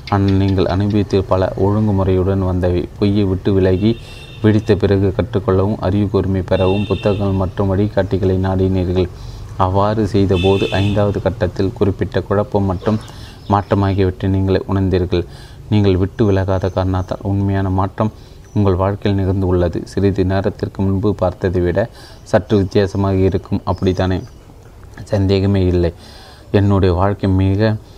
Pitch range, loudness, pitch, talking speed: 95-105 Hz, -16 LUFS, 100 Hz, 115 wpm